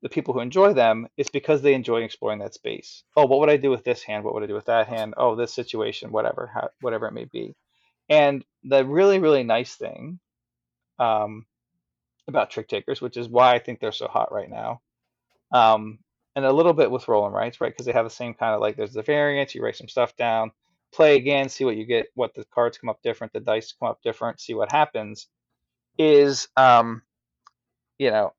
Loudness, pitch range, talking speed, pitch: -22 LUFS, 110-140 Hz, 220 wpm, 120 Hz